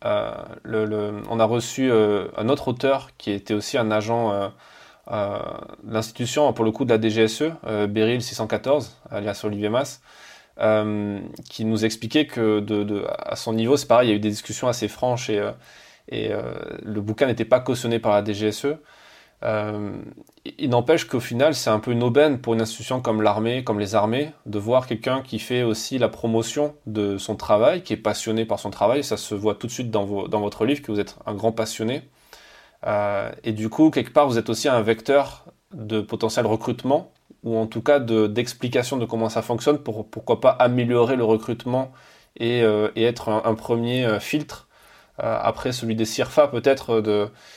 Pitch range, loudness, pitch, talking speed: 110-125 Hz, -23 LUFS, 115 Hz, 195 wpm